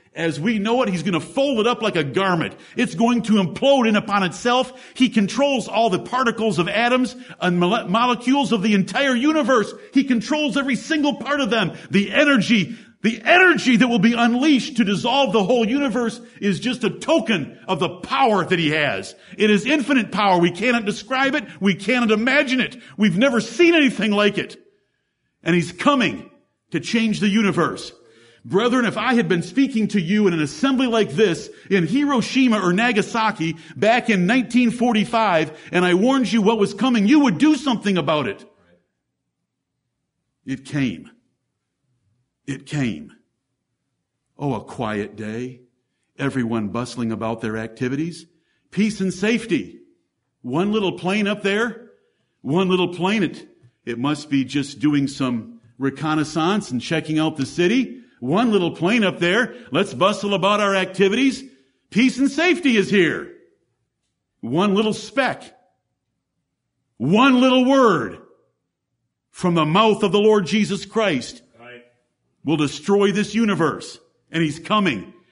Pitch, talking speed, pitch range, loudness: 210 Hz, 155 wpm, 165-245 Hz, -19 LUFS